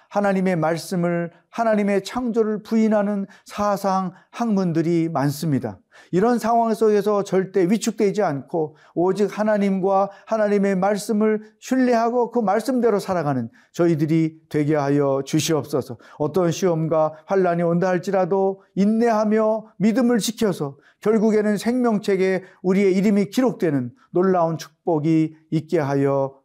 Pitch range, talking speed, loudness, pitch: 165-215 Hz, 305 characters per minute, -21 LUFS, 190 Hz